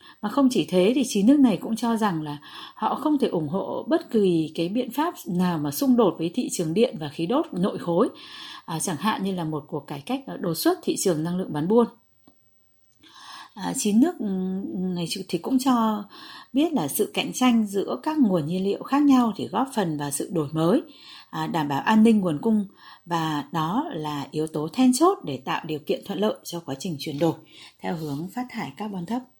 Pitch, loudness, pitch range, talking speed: 205 Hz, -24 LUFS, 165-255 Hz, 220 wpm